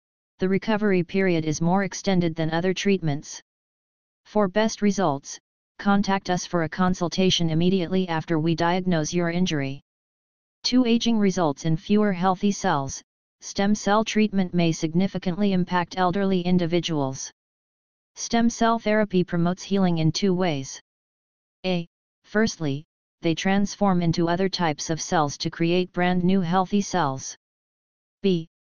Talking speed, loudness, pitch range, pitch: 130 wpm, -24 LUFS, 165-195 Hz, 180 Hz